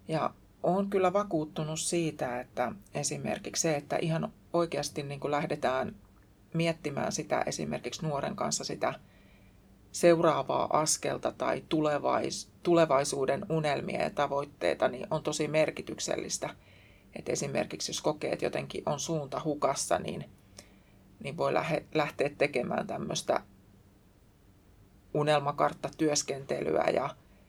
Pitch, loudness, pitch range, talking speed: 145 Hz, -31 LUFS, 100-160 Hz, 105 wpm